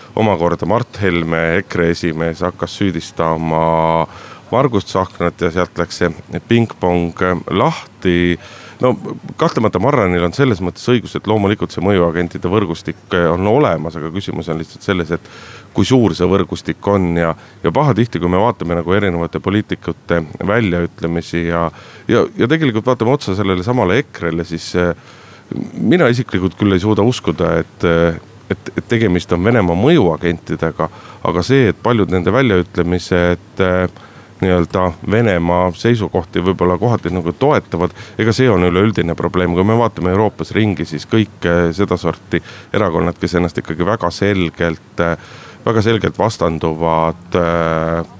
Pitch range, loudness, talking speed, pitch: 85-105 Hz, -16 LUFS, 135 wpm, 90 Hz